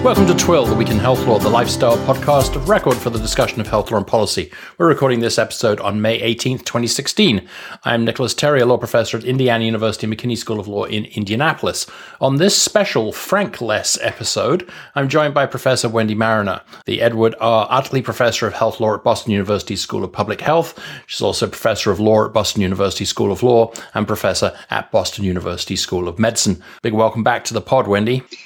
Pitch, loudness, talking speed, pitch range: 115 Hz, -17 LUFS, 200 wpm, 105-120 Hz